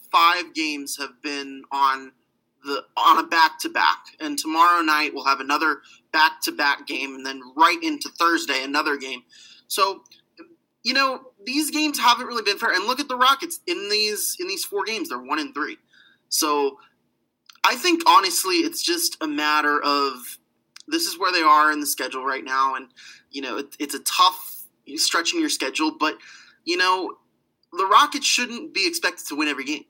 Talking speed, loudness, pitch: 190 wpm, -21 LUFS, 235 Hz